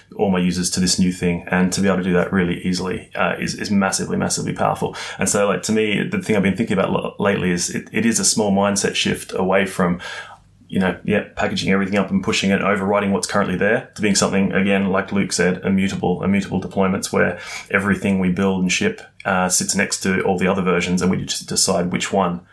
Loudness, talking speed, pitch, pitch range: -19 LUFS, 230 wpm, 95 Hz, 90-100 Hz